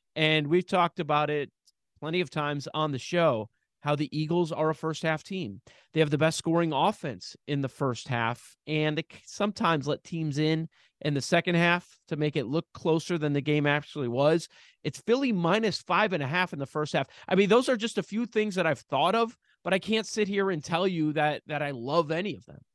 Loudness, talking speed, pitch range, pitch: -28 LUFS, 230 wpm, 150-180 Hz, 160 Hz